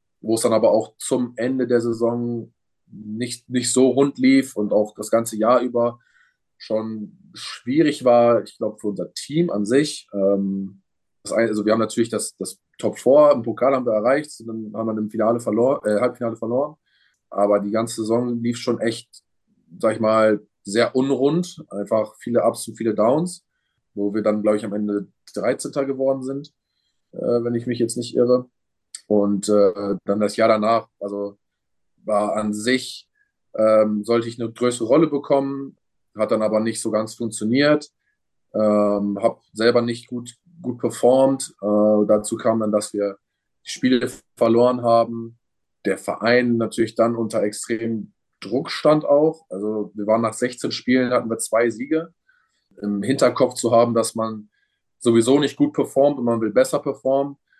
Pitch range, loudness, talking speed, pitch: 105-125 Hz, -21 LUFS, 170 wpm, 115 Hz